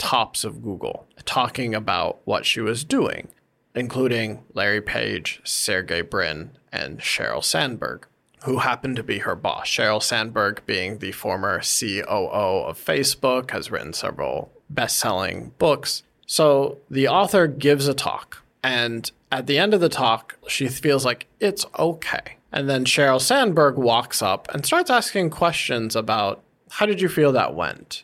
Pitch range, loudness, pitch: 120-165 Hz, -22 LUFS, 135 Hz